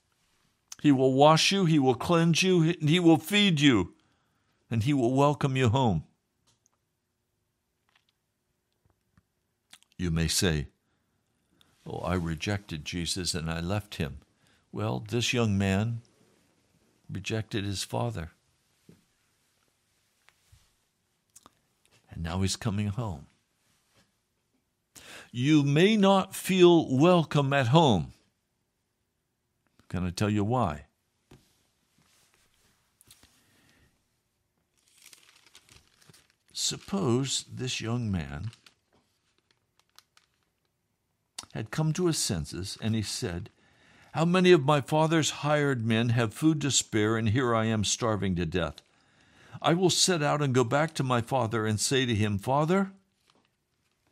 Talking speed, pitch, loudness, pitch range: 110 wpm, 120 Hz, -26 LUFS, 100-150 Hz